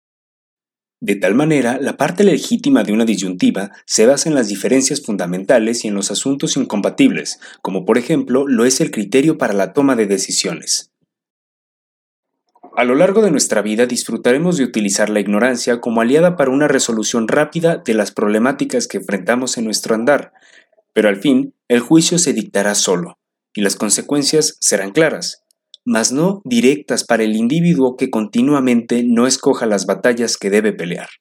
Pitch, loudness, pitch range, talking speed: 125 Hz, -15 LUFS, 110-155 Hz, 165 wpm